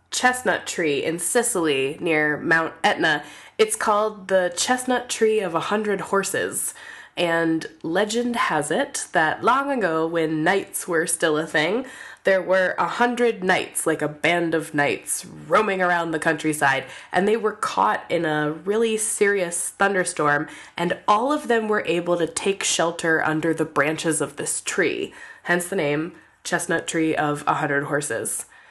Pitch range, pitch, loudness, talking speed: 160-210 Hz, 175 Hz, -22 LUFS, 160 wpm